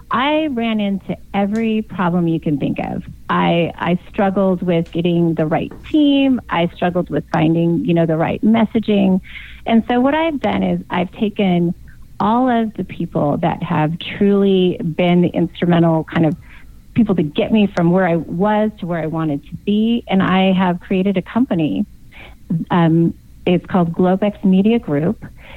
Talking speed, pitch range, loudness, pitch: 170 wpm, 170-210 Hz, -17 LUFS, 185 Hz